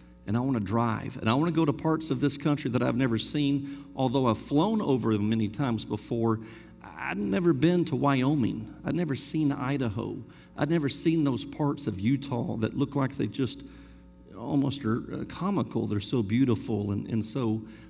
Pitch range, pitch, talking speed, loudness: 110-140 Hz, 130 Hz, 190 wpm, -28 LUFS